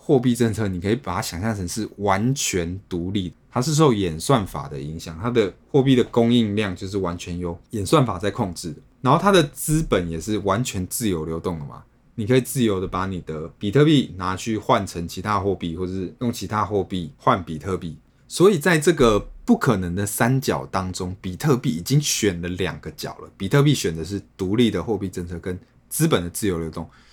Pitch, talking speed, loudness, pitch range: 100 Hz, 310 characters per minute, -22 LUFS, 90-120 Hz